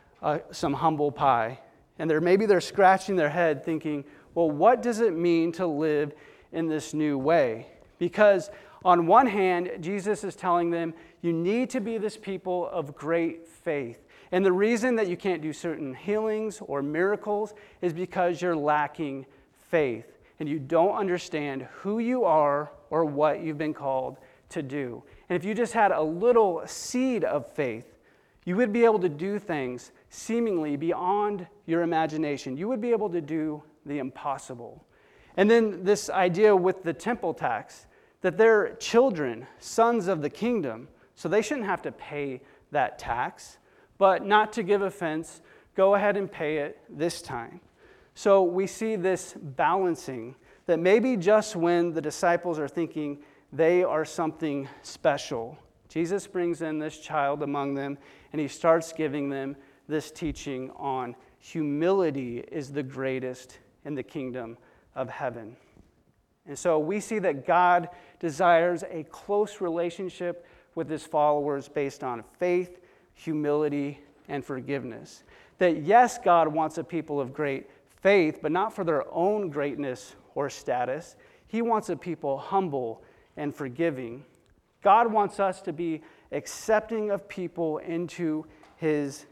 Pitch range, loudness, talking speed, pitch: 150-195 Hz, -27 LUFS, 155 wpm, 170 Hz